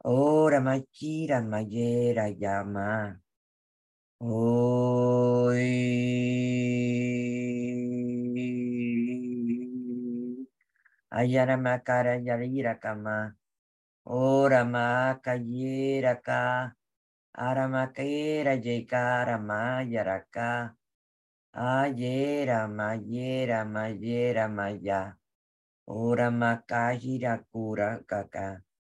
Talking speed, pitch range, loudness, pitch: 60 wpm, 110-125 Hz, -28 LUFS, 120 Hz